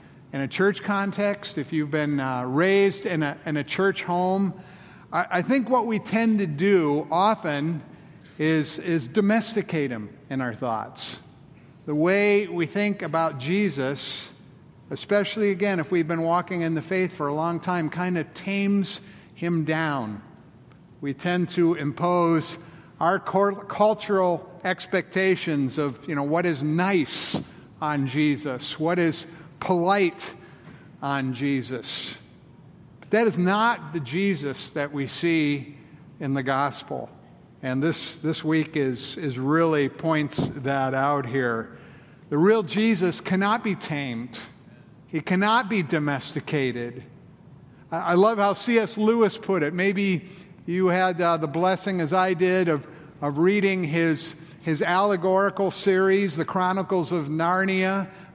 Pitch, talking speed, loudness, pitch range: 170 Hz, 140 wpm, -24 LUFS, 150-190 Hz